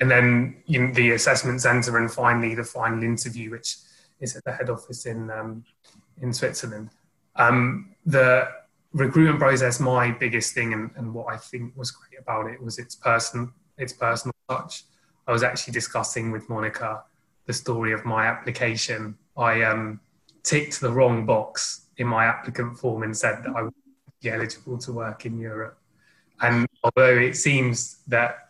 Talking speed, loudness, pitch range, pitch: 165 wpm, -23 LUFS, 115-130 Hz, 120 Hz